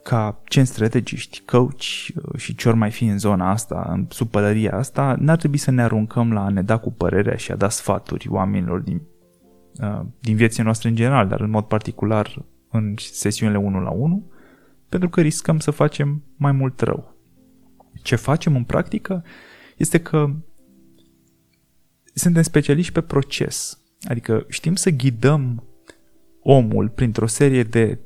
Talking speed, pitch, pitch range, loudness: 155 wpm, 120 Hz, 105-145 Hz, -20 LUFS